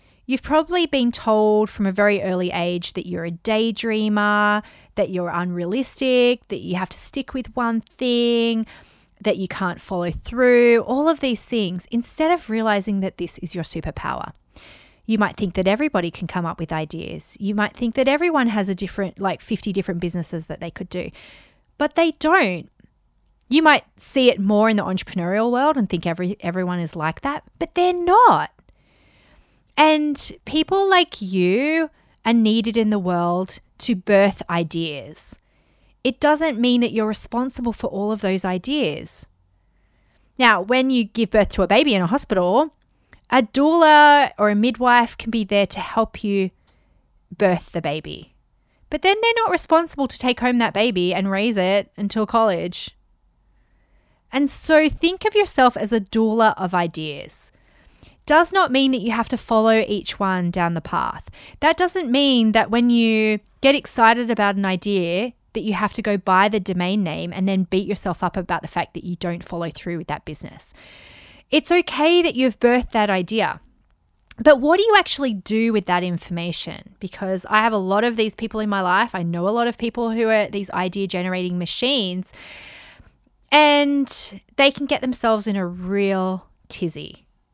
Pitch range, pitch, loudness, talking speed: 185-255 Hz, 215 Hz, -20 LUFS, 180 wpm